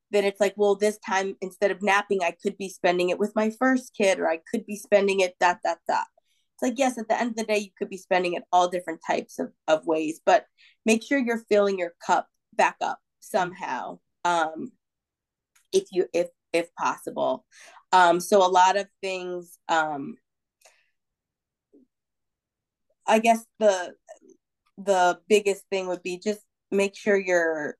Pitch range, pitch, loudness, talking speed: 180-225 Hz, 200 Hz, -25 LUFS, 175 wpm